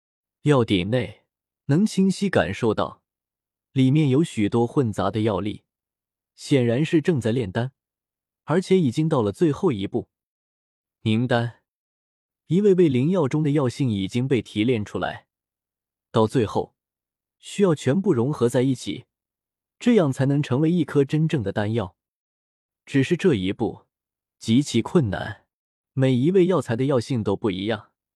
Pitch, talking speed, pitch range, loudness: 125 Hz, 215 characters per minute, 105-155 Hz, -22 LUFS